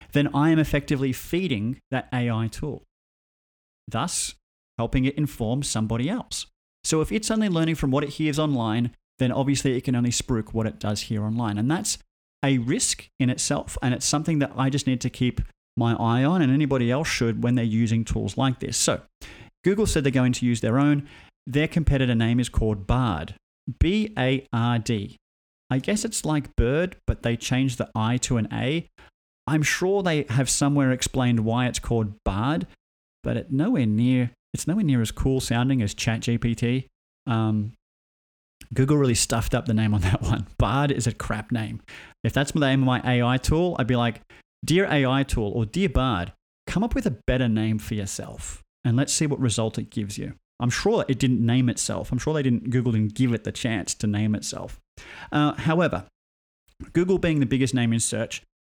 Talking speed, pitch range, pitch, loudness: 200 wpm, 110-140 Hz, 125 Hz, -24 LUFS